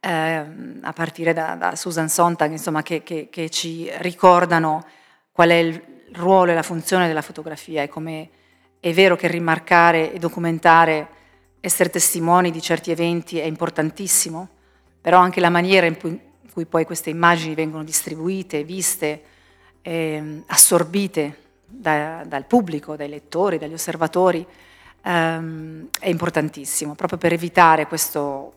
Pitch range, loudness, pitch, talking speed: 155-175 Hz, -19 LUFS, 165 Hz, 140 wpm